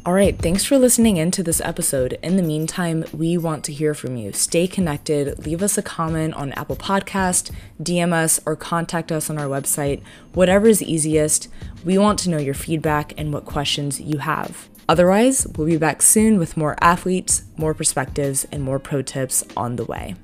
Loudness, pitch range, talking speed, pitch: -19 LUFS, 145-175 Hz, 195 wpm, 160 Hz